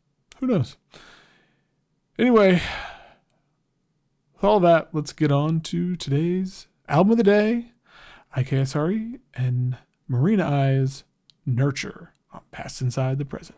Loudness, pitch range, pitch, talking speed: -22 LUFS, 135-195 Hz, 155 Hz, 110 wpm